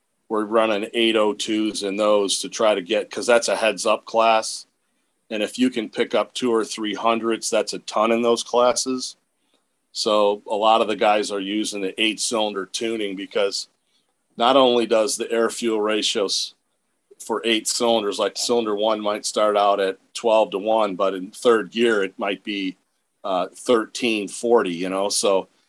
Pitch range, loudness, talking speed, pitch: 105-115 Hz, -21 LUFS, 180 wpm, 110 Hz